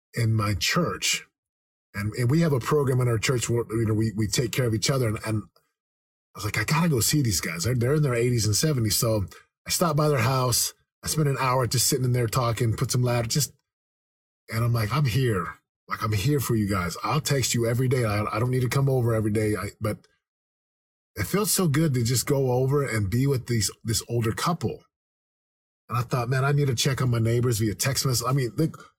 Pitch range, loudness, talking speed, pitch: 110-135 Hz, -24 LUFS, 245 wpm, 120 Hz